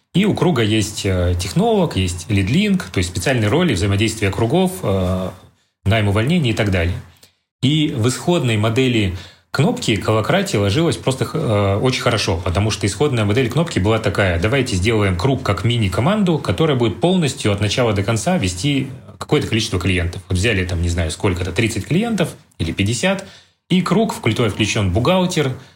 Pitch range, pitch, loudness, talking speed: 100-145 Hz, 115 Hz, -18 LUFS, 155 wpm